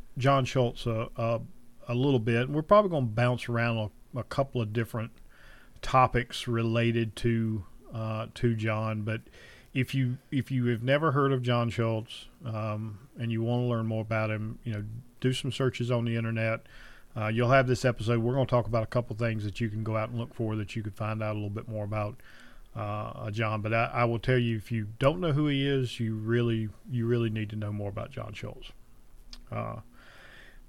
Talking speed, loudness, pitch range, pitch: 215 wpm, -30 LUFS, 110-125 Hz, 115 Hz